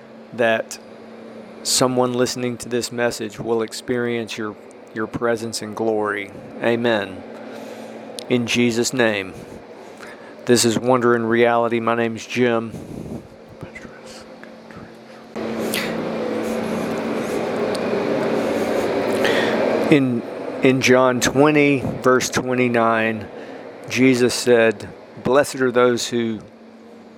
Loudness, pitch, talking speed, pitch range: -19 LUFS, 120 Hz, 85 wpm, 115-125 Hz